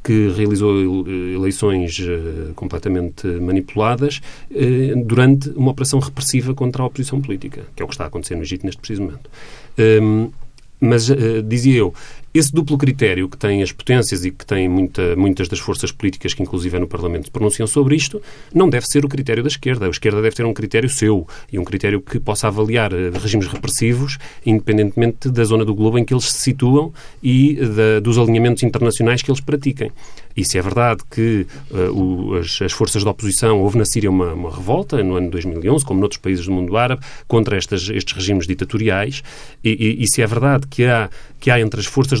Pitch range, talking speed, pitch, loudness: 95-130 Hz, 195 wpm, 110 Hz, -17 LUFS